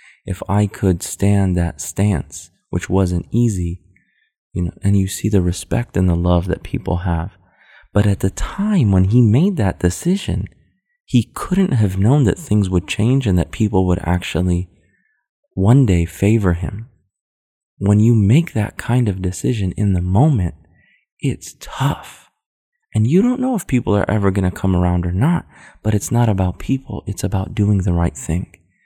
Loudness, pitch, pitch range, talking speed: -18 LUFS, 95 Hz, 90-110 Hz, 175 wpm